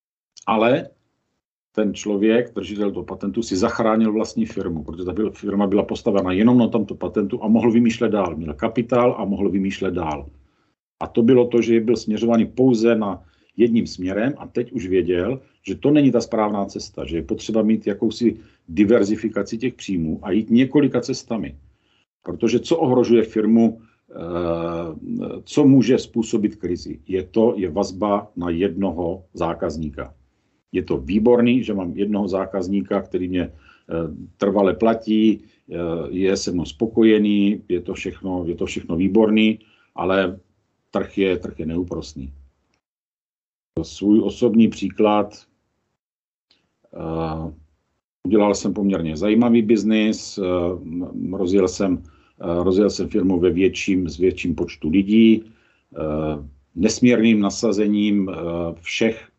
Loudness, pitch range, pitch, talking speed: -20 LUFS, 90-115 Hz, 100 Hz, 130 wpm